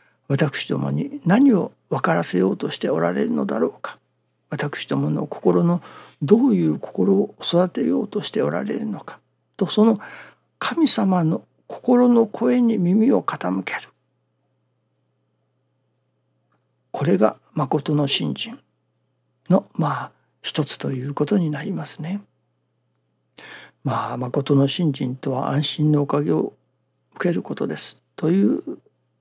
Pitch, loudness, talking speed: 145 Hz, -21 LUFS, 230 characters per minute